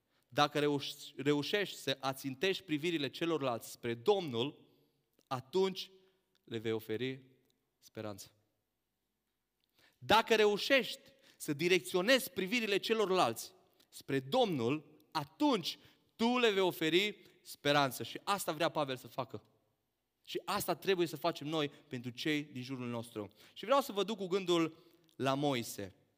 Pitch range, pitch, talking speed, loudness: 130-190 Hz, 150 Hz, 120 wpm, -35 LUFS